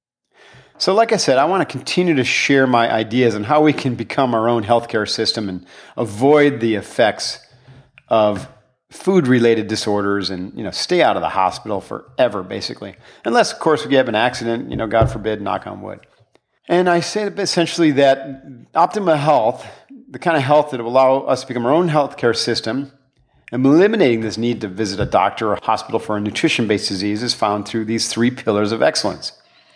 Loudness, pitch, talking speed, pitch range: -17 LUFS, 125 Hz, 190 wpm, 110-145 Hz